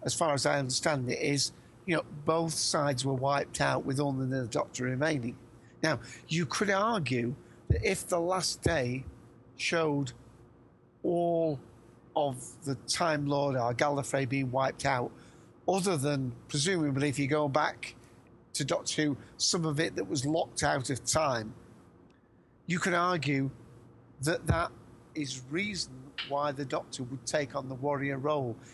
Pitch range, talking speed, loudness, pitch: 125-155 Hz, 155 wpm, -31 LUFS, 140 Hz